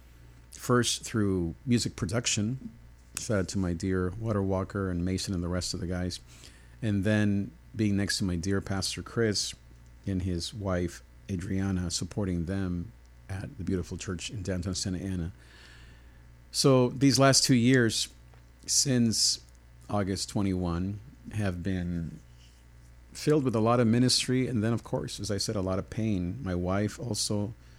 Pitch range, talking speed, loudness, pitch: 80-105 Hz, 150 wpm, -29 LUFS, 95 Hz